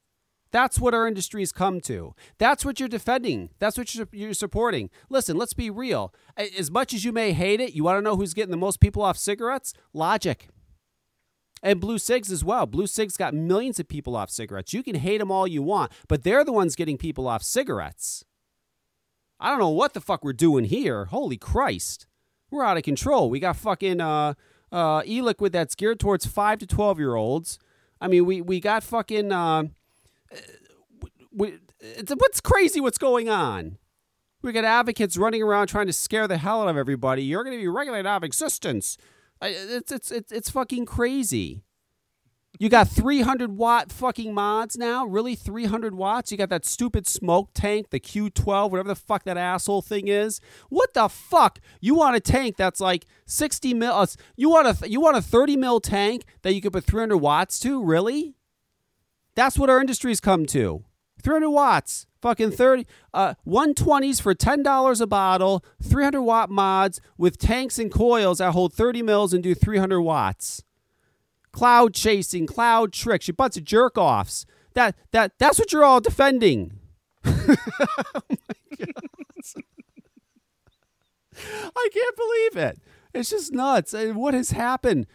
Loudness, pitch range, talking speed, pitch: -23 LUFS, 185-250 Hz, 175 wpm, 215 Hz